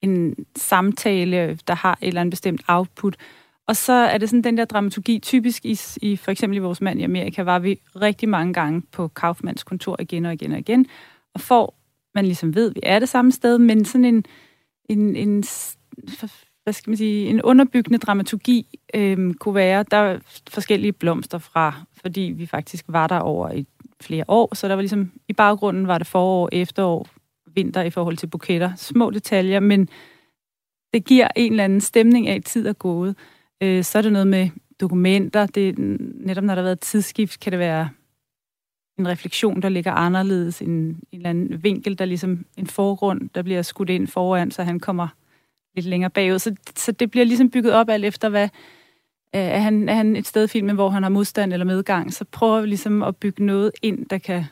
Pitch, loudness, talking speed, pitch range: 195 Hz, -20 LUFS, 200 wpm, 180-215 Hz